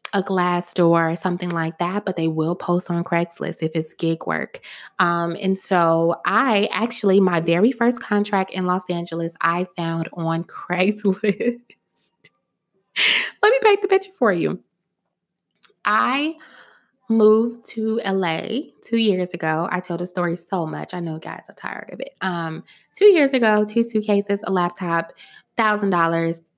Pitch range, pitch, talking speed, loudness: 170-215 Hz, 185 Hz, 160 wpm, -21 LUFS